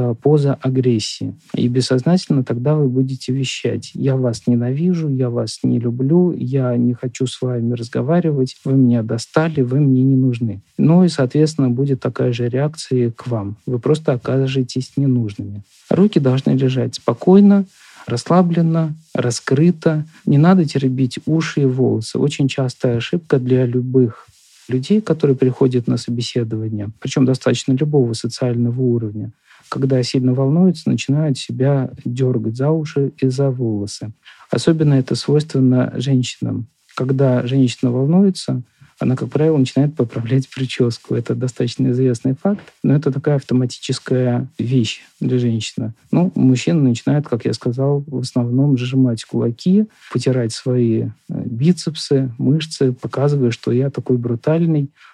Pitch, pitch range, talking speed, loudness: 130 Hz, 125-145 Hz, 135 wpm, -17 LUFS